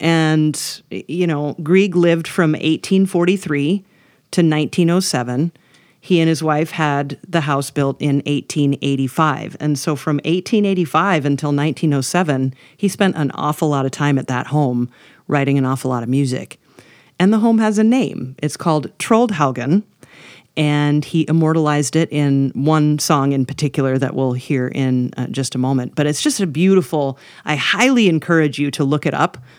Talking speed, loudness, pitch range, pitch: 160 wpm, -17 LUFS, 140-170 Hz, 150 Hz